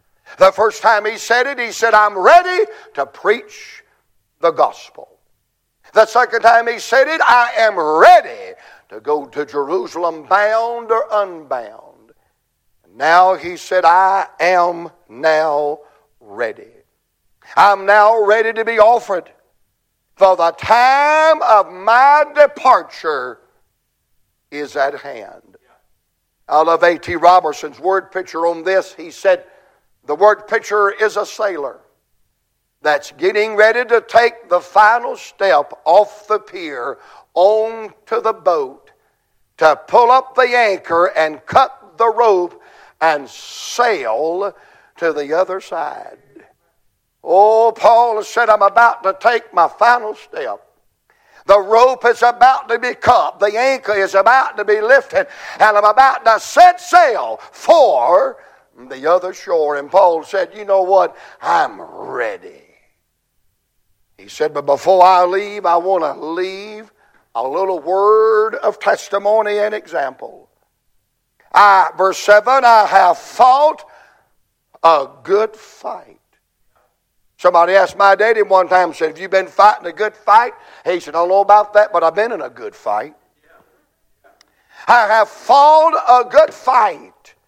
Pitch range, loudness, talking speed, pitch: 180-240 Hz, -13 LUFS, 135 wpm, 210 Hz